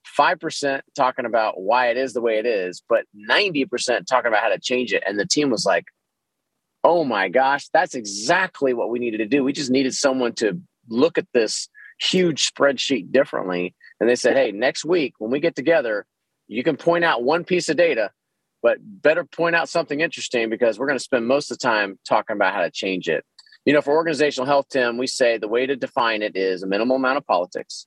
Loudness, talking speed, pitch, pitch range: -21 LUFS, 220 wpm, 135 Hz, 120-160 Hz